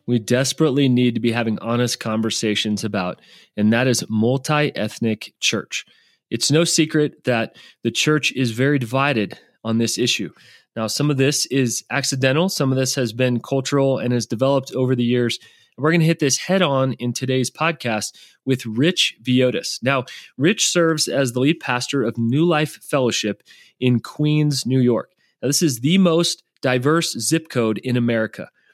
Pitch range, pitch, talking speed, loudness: 115-145 Hz, 130 Hz, 175 wpm, -20 LUFS